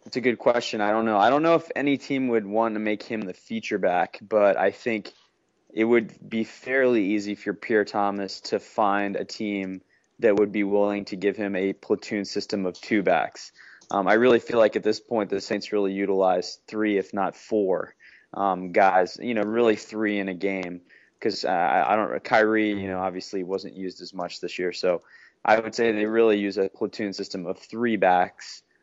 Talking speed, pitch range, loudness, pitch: 210 wpm, 95-110 Hz, -24 LUFS, 105 Hz